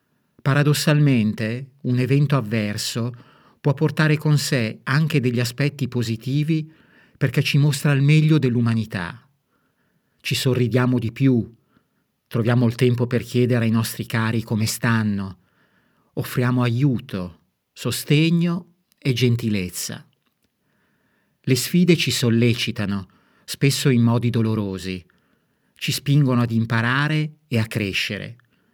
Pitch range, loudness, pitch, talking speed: 115-145 Hz, -21 LUFS, 125 Hz, 110 wpm